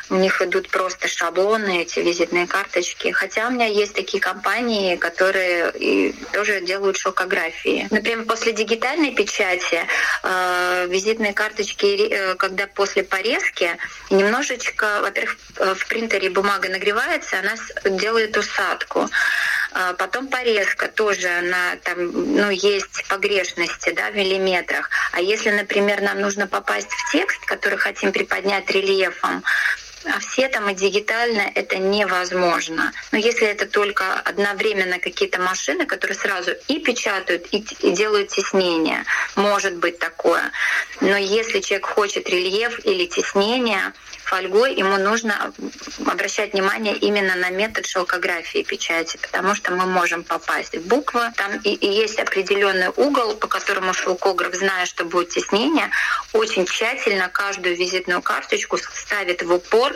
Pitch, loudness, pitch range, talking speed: 200 Hz, -20 LUFS, 185-225 Hz, 130 wpm